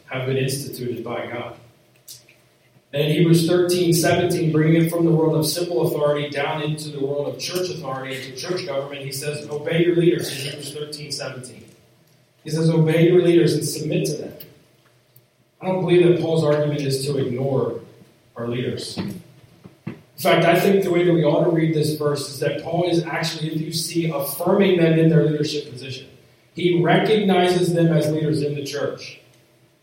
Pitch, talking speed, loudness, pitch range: 150 Hz, 185 wpm, -20 LUFS, 135-170 Hz